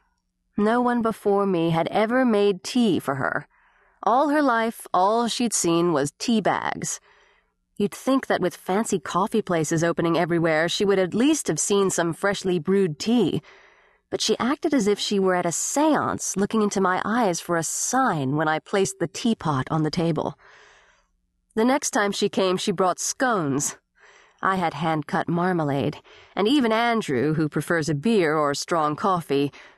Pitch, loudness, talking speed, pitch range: 195 Hz, -23 LUFS, 175 wpm, 165-225 Hz